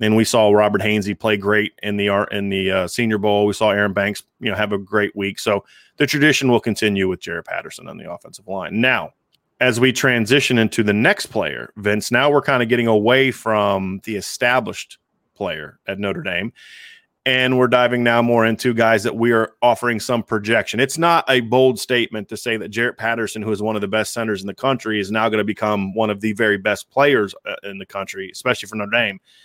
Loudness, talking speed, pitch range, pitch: -18 LUFS, 225 wpm, 105-125 Hz, 110 Hz